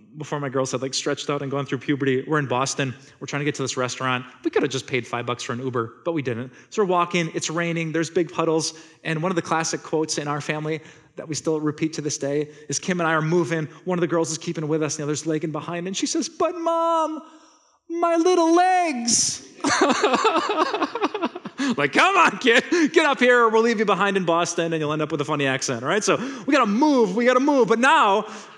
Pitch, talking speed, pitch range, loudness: 160 Hz, 245 wpm, 145-215 Hz, -22 LUFS